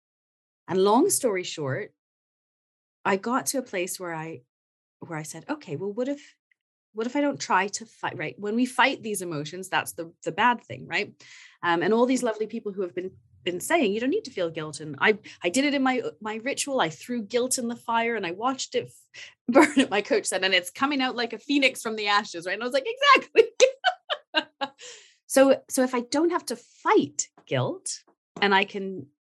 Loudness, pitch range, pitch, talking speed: -25 LUFS, 185-275 Hz, 235 Hz, 215 wpm